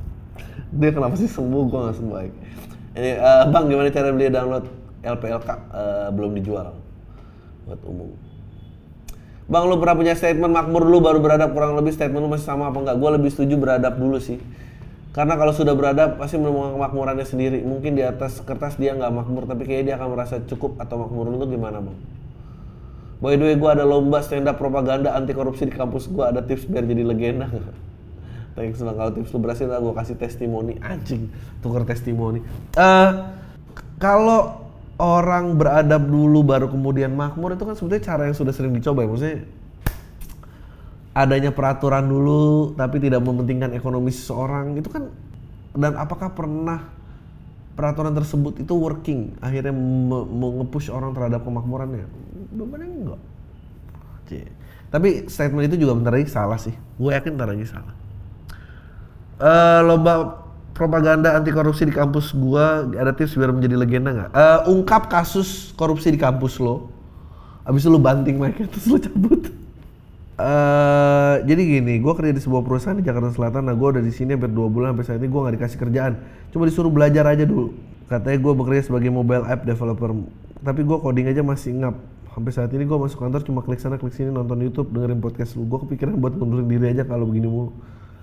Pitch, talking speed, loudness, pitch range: 130 Hz, 175 wpm, -20 LUFS, 120-150 Hz